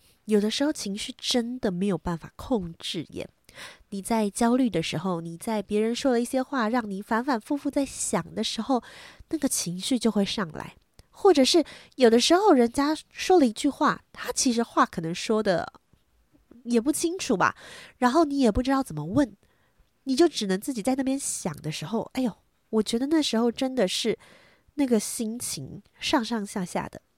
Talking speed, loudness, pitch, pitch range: 265 characters per minute, -26 LUFS, 235 Hz, 205-270 Hz